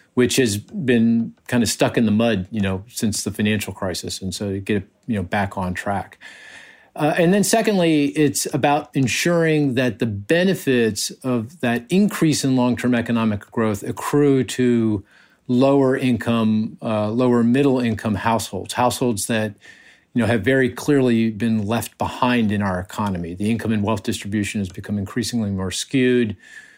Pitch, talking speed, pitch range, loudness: 115 Hz, 155 wpm, 105-130 Hz, -20 LUFS